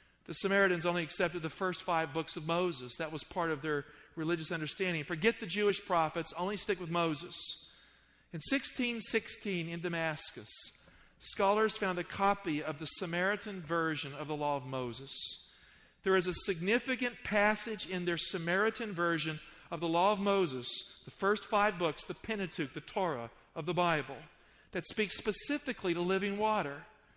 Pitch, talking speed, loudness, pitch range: 175 Hz, 160 wpm, -34 LUFS, 160-200 Hz